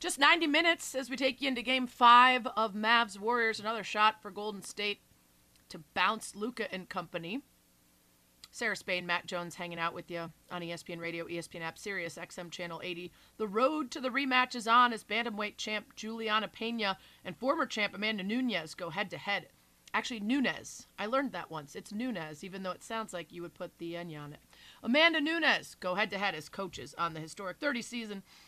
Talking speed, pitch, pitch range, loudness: 200 wpm, 205 Hz, 170-240 Hz, -32 LUFS